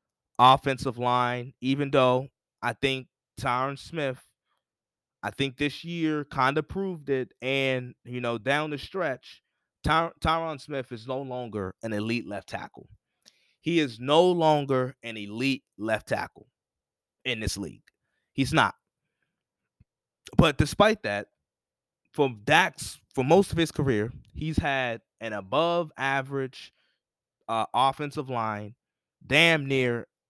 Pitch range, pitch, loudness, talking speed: 125-150 Hz, 135 Hz, -27 LUFS, 125 wpm